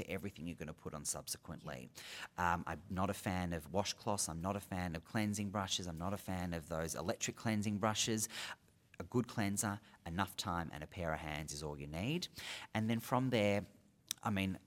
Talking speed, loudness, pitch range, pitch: 205 wpm, -40 LUFS, 85-105 Hz, 95 Hz